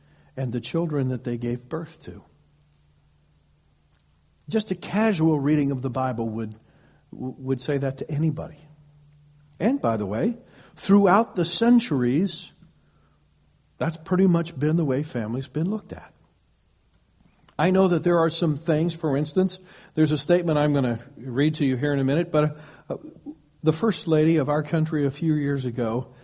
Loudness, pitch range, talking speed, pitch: -24 LUFS, 130-165 Hz, 165 wpm, 150 Hz